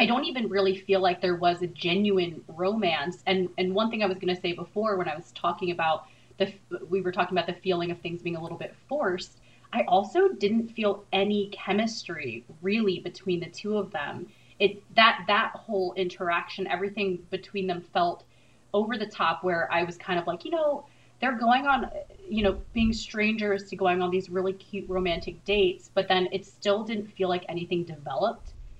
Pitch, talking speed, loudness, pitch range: 190 Hz, 200 wpm, -28 LUFS, 175-205 Hz